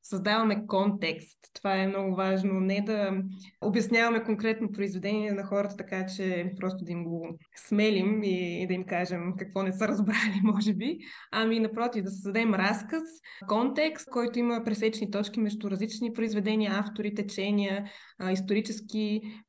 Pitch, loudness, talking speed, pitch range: 205 Hz, -29 LUFS, 140 wpm, 190-220 Hz